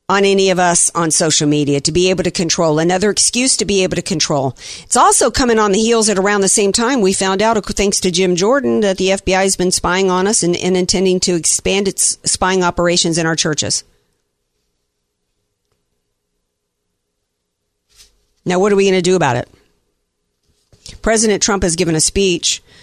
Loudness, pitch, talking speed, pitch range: -13 LUFS, 180 Hz, 185 wpm, 120-195 Hz